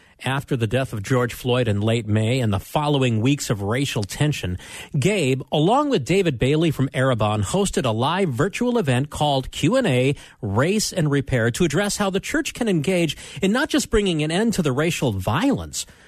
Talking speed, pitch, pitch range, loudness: 185 wpm, 140 Hz, 120-185 Hz, -21 LUFS